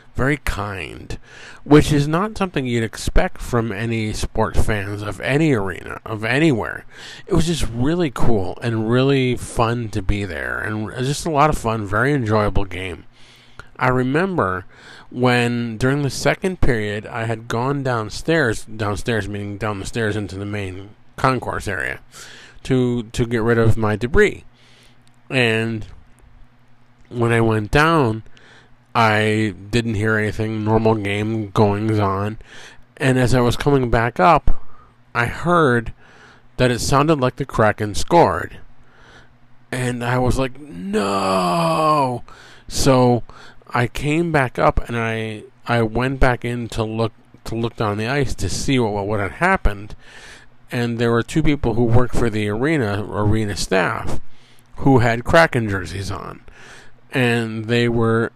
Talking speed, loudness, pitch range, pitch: 145 wpm, -19 LUFS, 110-125 Hz, 120 Hz